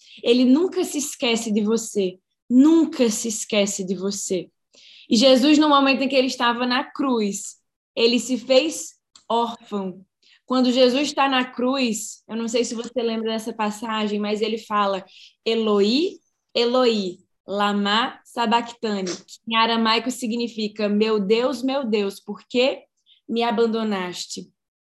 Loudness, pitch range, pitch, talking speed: -21 LUFS, 210-255 Hz, 230 Hz, 135 wpm